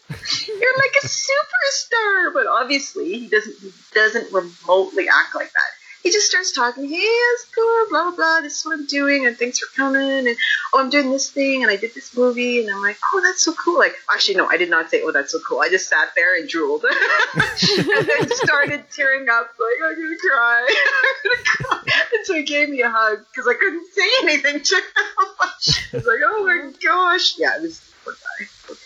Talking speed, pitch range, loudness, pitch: 220 wpm, 265-375 Hz, -17 LUFS, 295 Hz